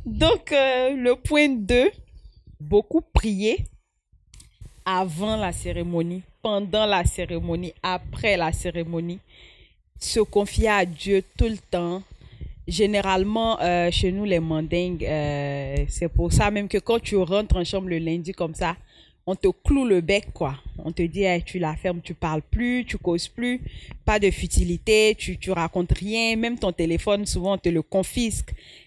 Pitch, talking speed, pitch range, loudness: 185 Hz, 165 wpm, 170-210 Hz, -24 LUFS